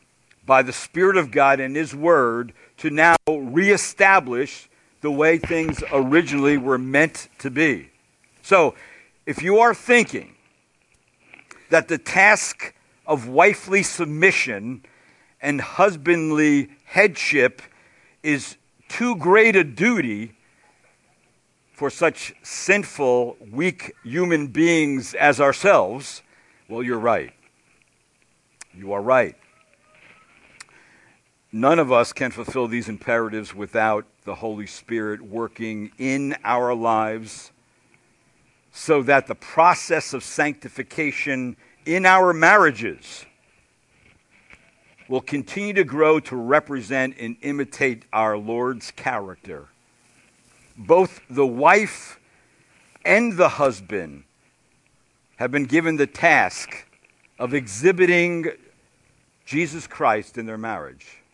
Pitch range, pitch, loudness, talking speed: 120-165 Hz, 140 Hz, -20 LUFS, 105 wpm